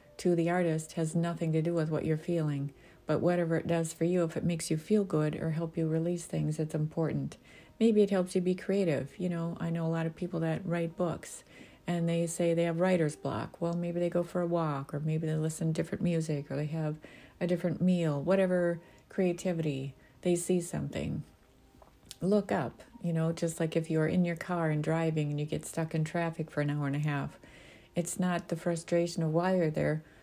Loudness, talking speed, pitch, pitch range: -32 LUFS, 220 wpm, 165 Hz, 155-175 Hz